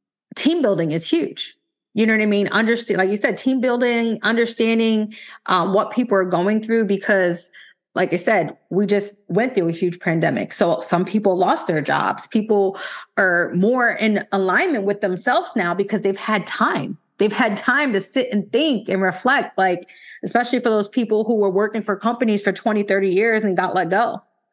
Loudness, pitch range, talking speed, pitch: -19 LUFS, 195-230 Hz, 190 wpm, 210 Hz